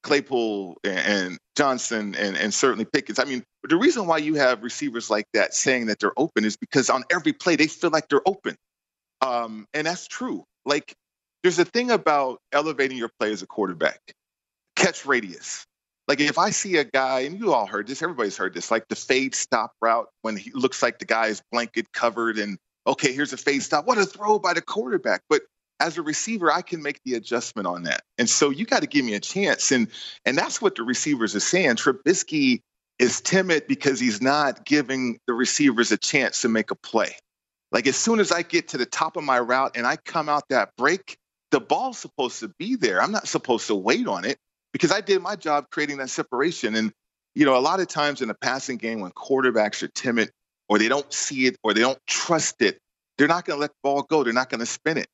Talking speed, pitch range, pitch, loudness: 225 wpm, 130-190 Hz, 150 Hz, -23 LUFS